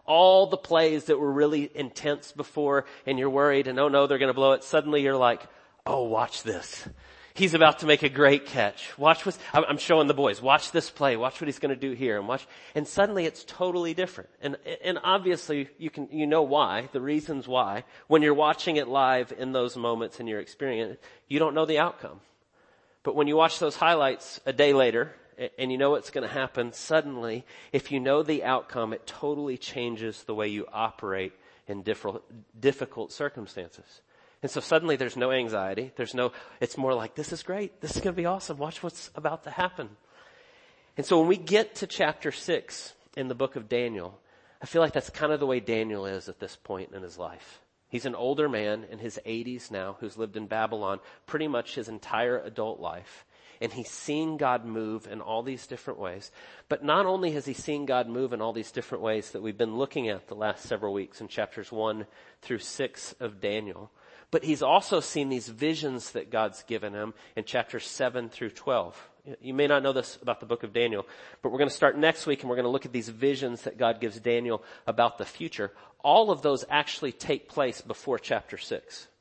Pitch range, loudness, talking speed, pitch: 120-155 Hz, -28 LUFS, 210 wpm, 135 Hz